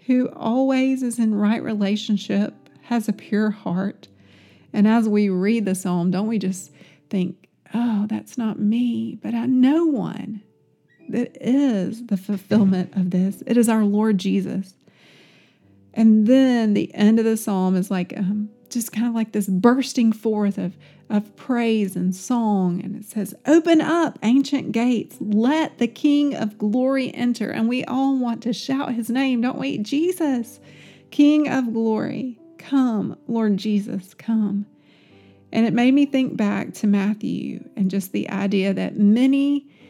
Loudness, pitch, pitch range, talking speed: -21 LUFS, 220 Hz, 200-250 Hz, 160 wpm